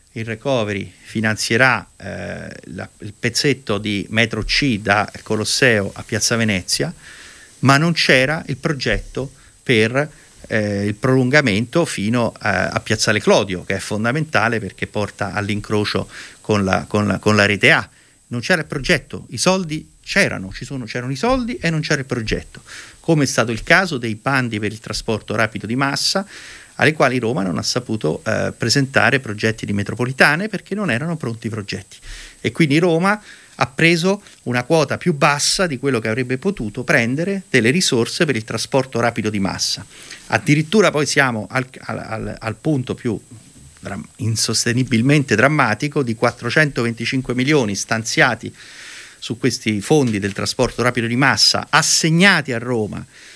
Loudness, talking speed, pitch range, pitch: -18 LUFS, 155 wpm, 105-145 Hz, 120 Hz